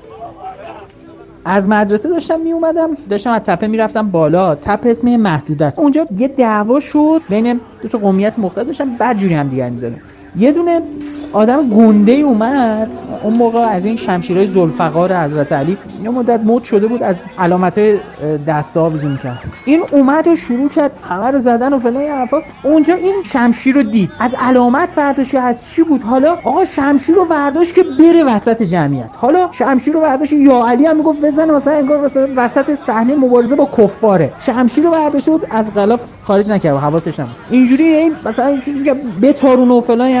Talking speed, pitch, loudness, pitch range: 170 wpm, 245 Hz, -12 LUFS, 205-290 Hz